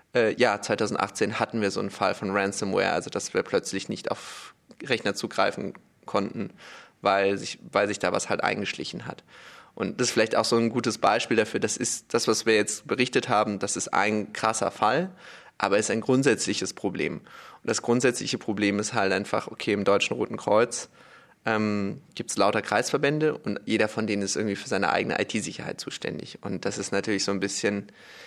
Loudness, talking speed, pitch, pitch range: -26 LUFS, 195 wpm, 105 Hz, 100-110 Hz